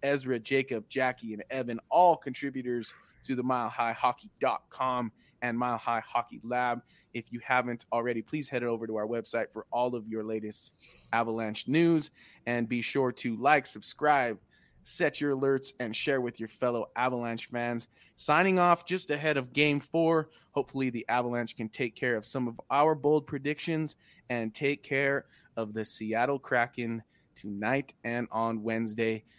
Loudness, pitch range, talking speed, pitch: -30 LUFS, 115-140 Hz, 160 wpm, 125 Hz